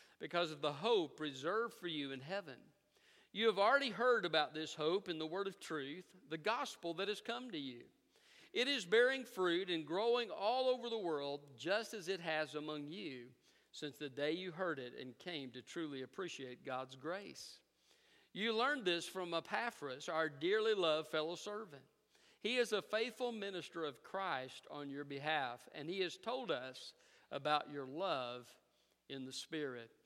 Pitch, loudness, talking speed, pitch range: 170 Hz, -40 LUFS, 175 wpm, 145-225 Hz